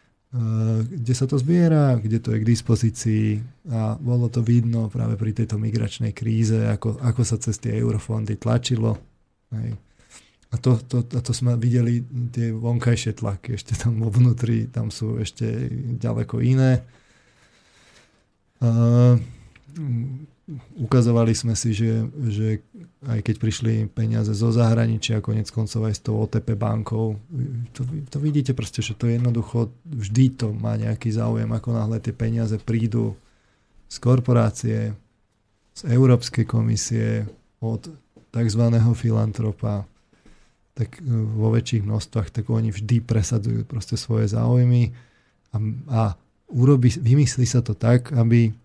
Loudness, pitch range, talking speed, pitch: -22 LUFS, 110-120 Hz, 130 wpm, 115 Hz